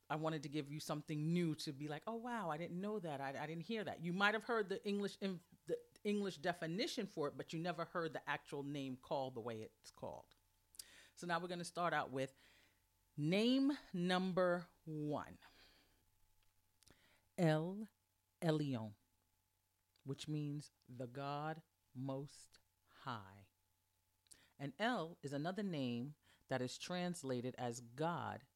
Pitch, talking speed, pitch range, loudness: 150 Hz, 155 wpm, 120-175 Hz, -43 LUFS